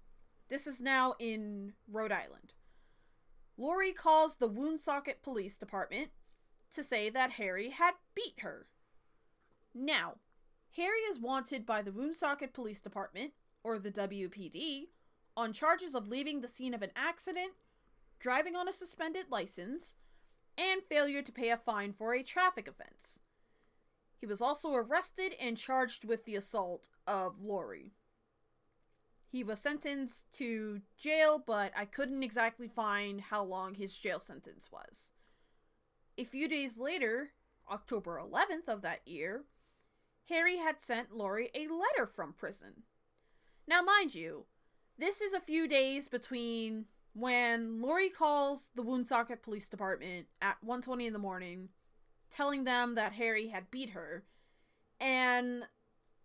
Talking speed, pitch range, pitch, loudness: 135 wpm, 215-300 Hz, 250 Hz, -36 LUFS